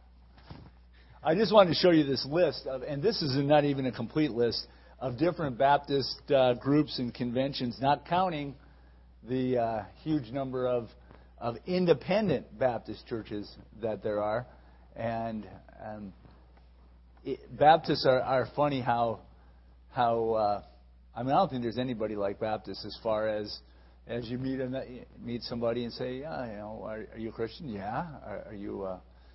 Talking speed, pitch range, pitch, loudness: 170 wpm, 90-135 Hz, 115 Hz, -30 LUFS